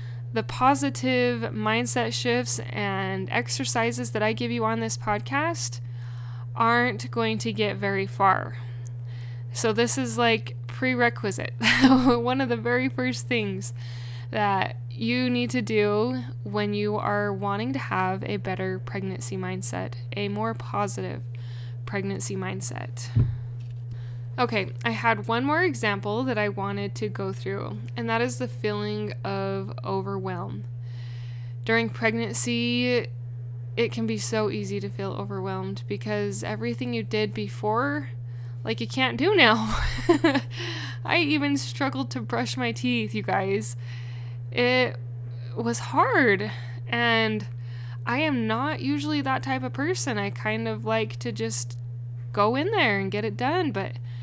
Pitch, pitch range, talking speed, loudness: 120 Hz, 110-120 Hz, 135 wpm, -26 LUFS